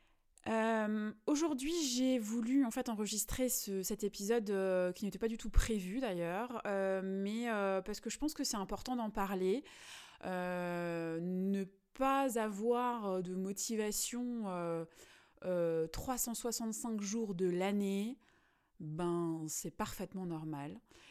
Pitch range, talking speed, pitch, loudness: 185-235 Hz, 130 wpm, 210 Hz, -37 LUFS